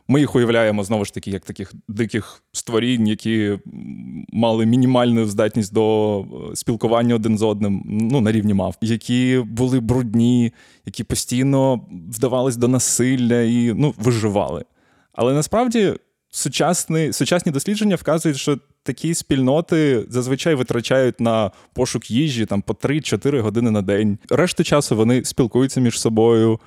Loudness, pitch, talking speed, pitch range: -19 LUFS, 120 Hz, 135 wpm, 110-135 Hz